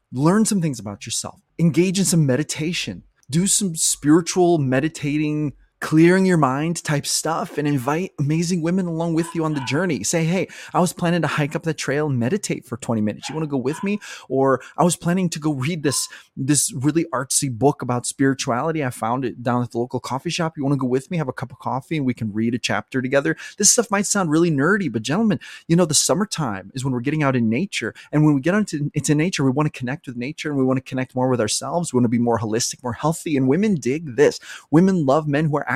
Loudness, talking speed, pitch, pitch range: -21 LUFS, 245 wpm, 150 Hz, 130-170 Hz